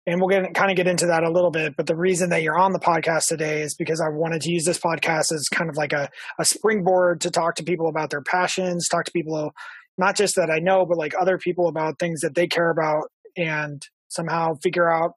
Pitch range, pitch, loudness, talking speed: 160-180 Hz, 170 Hz, -22 LUFS, 255 wpm